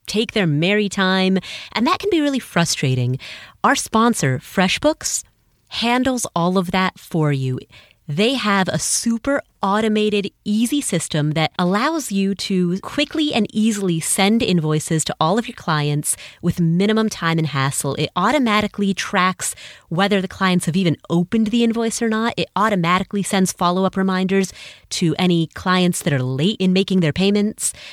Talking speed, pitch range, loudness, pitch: 160 wpm, 165-215 Hz, -19 LUFS, 190 Hz